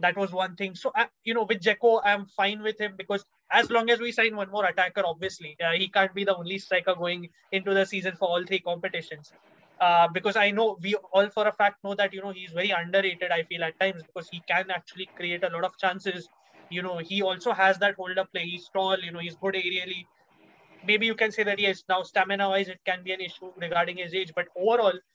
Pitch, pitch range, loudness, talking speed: 190 Hz, 180-200 Hz, -26 LUFS, 245 wpm